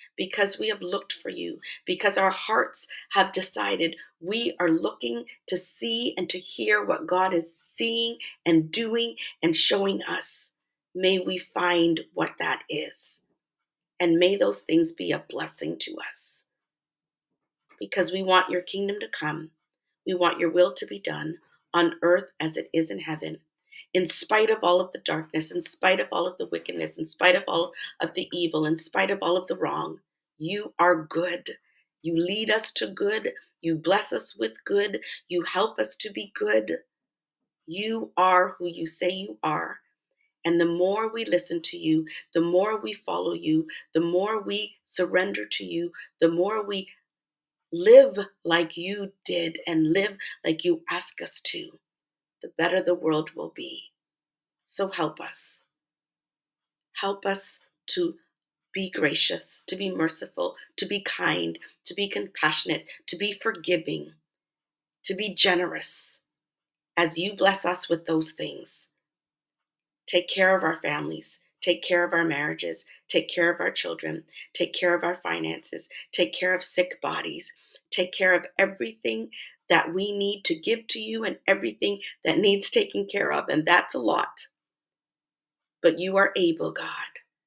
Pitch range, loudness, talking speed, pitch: 165-200 Hz, -25 LUFS, 165 wpm, 180 Hz